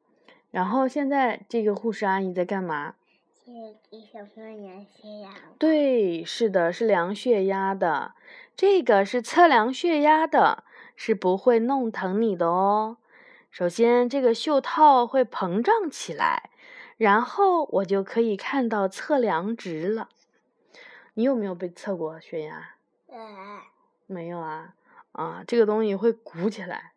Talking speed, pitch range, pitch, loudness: 200 characters per minute, 195-275 Hz, 225 Hz, -23 LUFS